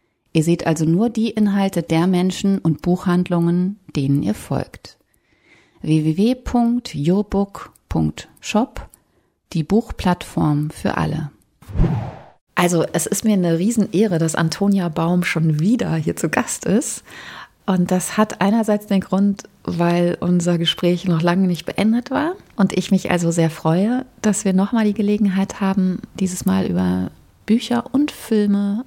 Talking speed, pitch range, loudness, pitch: 135 wpm, 165-210 Hz, -19 LUFS, 185 Hz